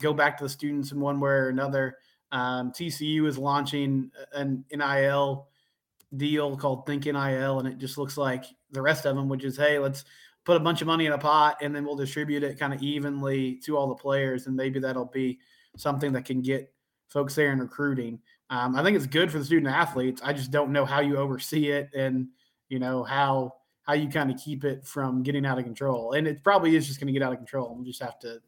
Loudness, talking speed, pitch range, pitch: -27 LUFS, 240 wpm, 130-145 Hz, 140 Hz